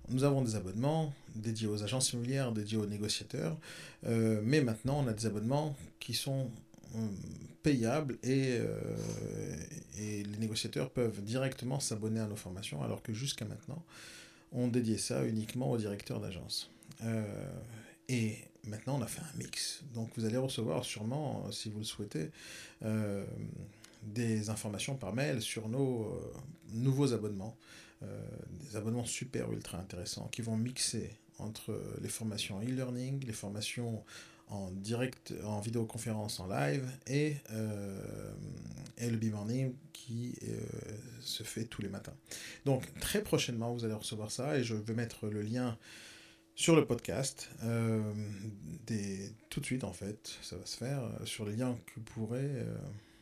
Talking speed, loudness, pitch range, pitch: 155 wpm, -37 LUFS, 110-130 Hz, 115 Hz